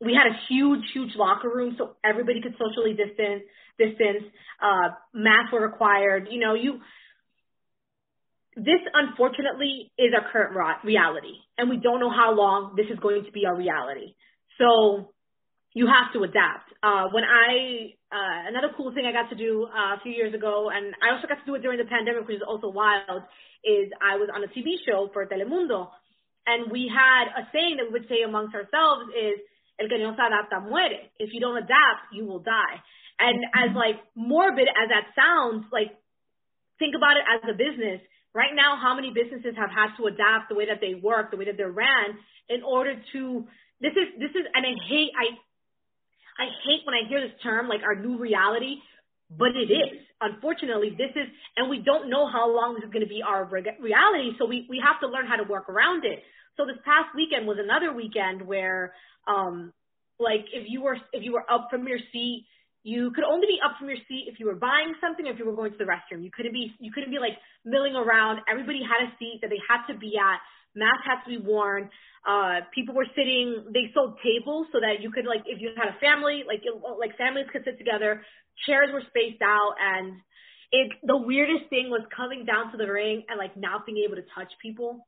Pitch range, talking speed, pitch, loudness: 215-260 Hz, 210 wpm, 235 Hz, -24 LUFS